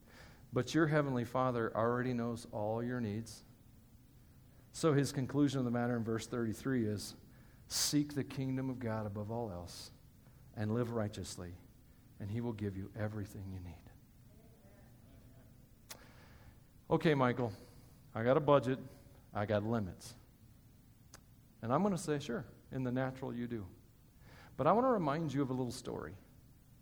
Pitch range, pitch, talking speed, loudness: 110-130 Hz, 120 Hz, 150 wpm, -37 LUFS